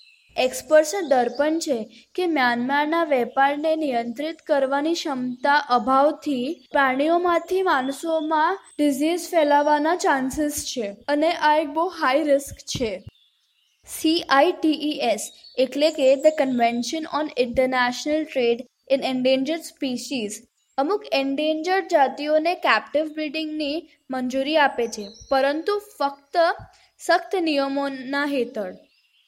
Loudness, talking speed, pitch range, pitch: -22 LUFS, 95 wpm, 260-315 Hz, 290 Hz